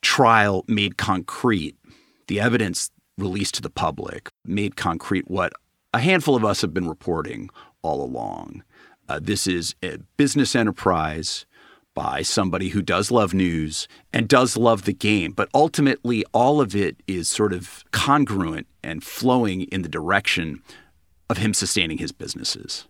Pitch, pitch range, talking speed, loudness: 100 Hz, 90-115 Hz, 150 wpm, -22 LUFS